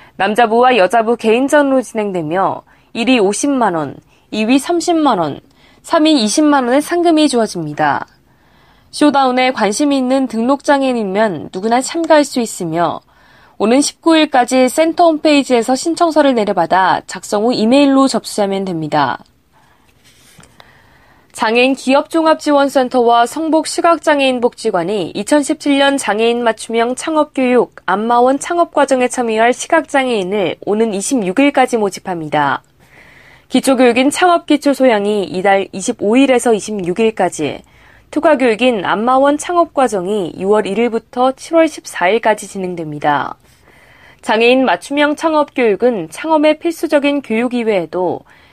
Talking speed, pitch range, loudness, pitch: 280 characters per minute, 205-285 Hz, -13 LUFS, 250 Hz